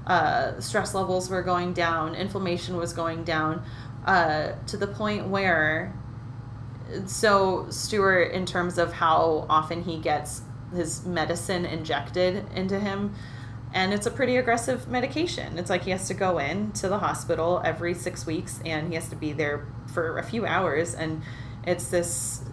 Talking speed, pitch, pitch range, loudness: 160 wpm, 165 Hz, 125-185 Hz, -26 LUFS